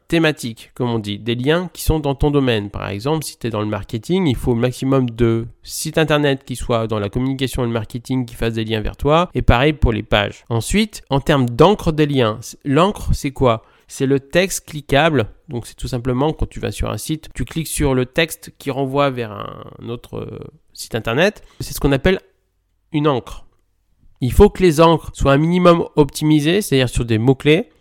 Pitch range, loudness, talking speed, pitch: 115-155 Hz, -18 LUFS, 215 wpm, 130 Hz